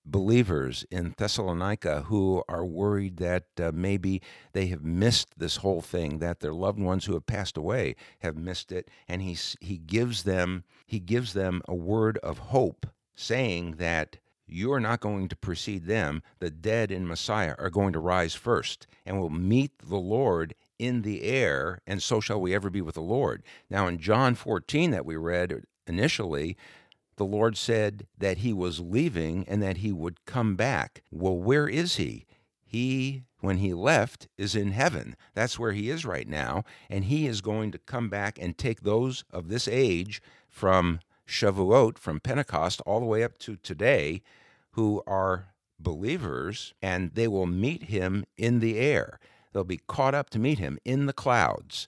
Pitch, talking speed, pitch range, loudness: 100 Hz, 180 wpm, 90-115 Hz, -28 LUFS